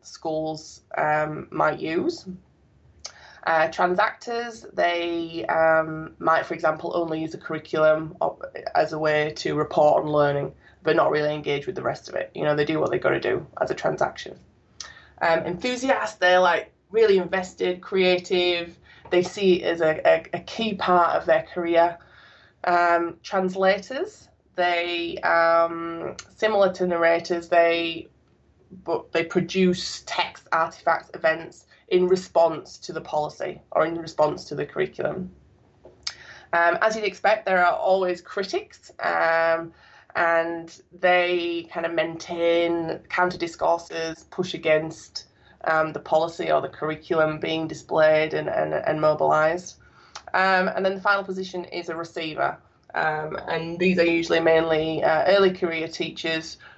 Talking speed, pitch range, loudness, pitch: 145 wpm, 160-180 Hz, -23 LUFS, 170 Hz